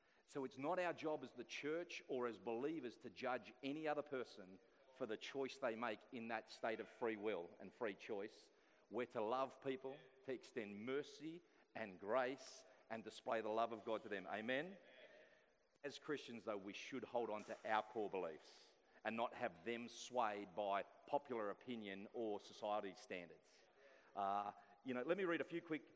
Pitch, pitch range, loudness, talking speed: 120 Hz, 105-140 Hz, -48 LUFS, 185 wpm